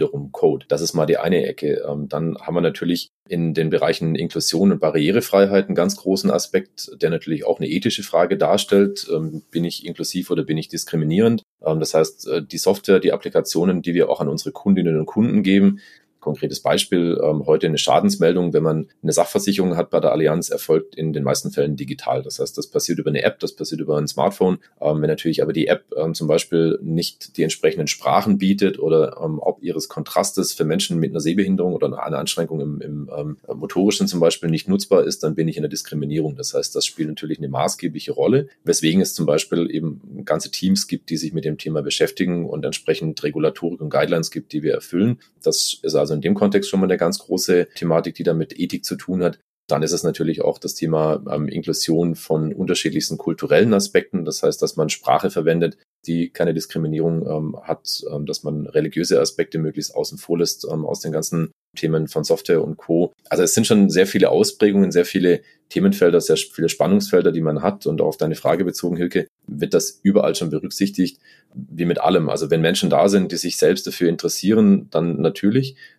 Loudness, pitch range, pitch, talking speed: -20 LUFS, 80-100 Hz, 85 Hz, 205 wpm